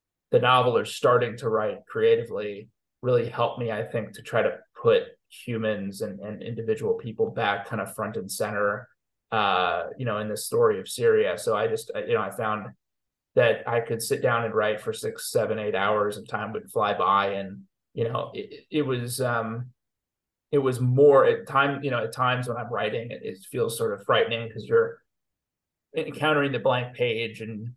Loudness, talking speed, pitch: -25 LUFS, 195 wpm, 145 Hz